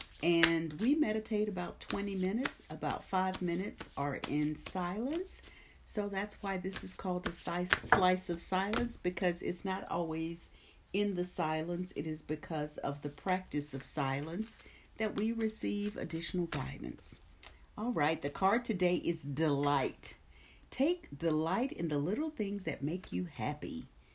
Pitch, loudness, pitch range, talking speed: 180 Hz, -34 LUFS, 155-205 Hz, 145 wpm